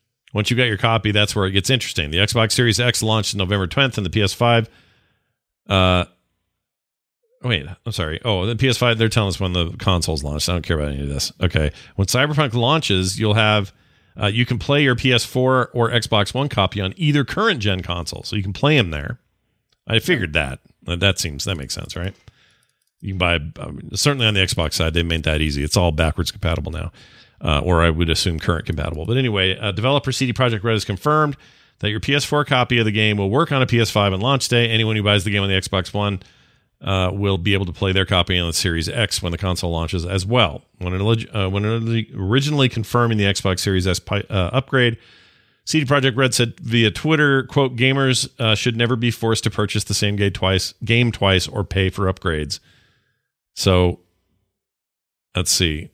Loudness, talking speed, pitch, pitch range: -19 LUFS, 210 wpm, 105 Hz, 90-120 Hz